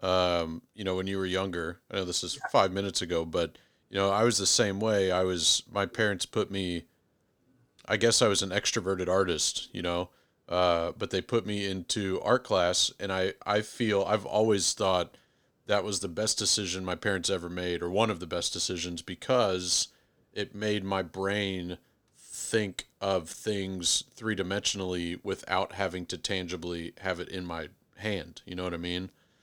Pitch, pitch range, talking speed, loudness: 95 Hz, 90-105 Hz, 185 wpm, -29 LUFS